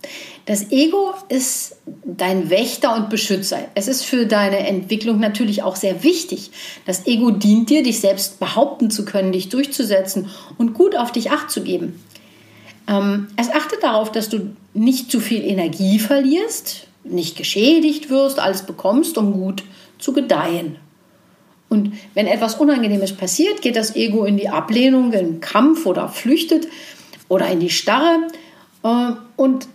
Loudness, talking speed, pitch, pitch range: -18 LUFS, 150 wpm, 225 Hz, 195-285 Hz